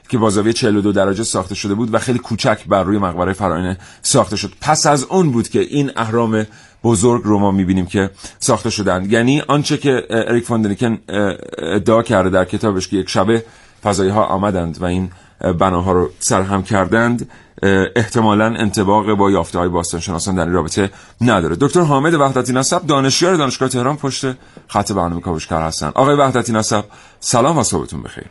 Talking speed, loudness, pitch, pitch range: 165 wpm, -16 LUFS, 105 Hz, 95-120 Hz